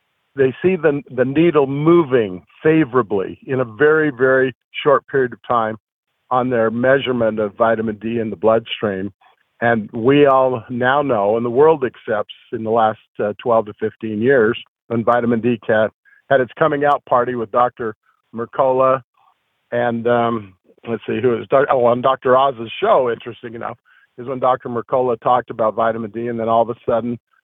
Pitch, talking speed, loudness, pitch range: 120 Hz, 175 wpm, -17 LUFS, 115-130 Hz